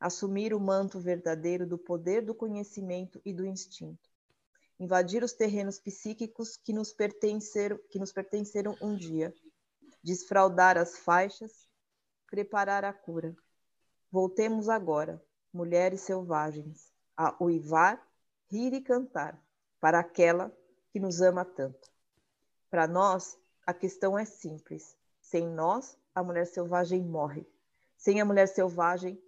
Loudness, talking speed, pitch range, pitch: -30 LUFS, 125 wpm, 175-205 Hz, 190 Hz